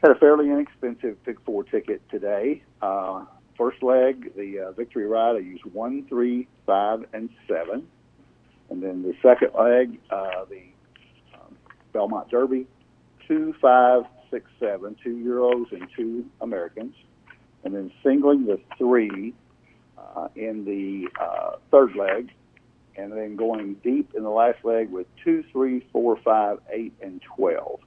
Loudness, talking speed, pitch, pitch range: -23 LUFS, 145 wpm, 125 Hz, 115-135 Hz